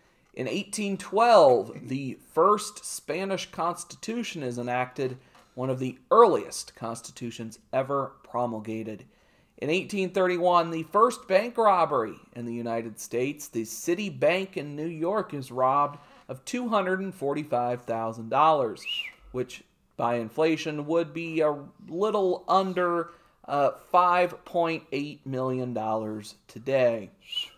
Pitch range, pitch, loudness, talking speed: 125-180 Hz, 145 Hz, -27 LUFS, 100 wpm